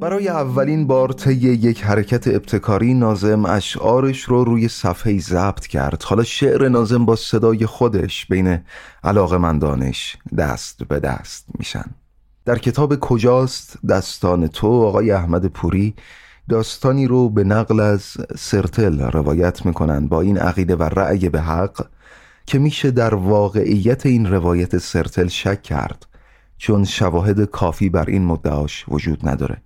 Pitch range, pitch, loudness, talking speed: 90-120 Hz, 105 Hz, -18 LUFS, 135 wpm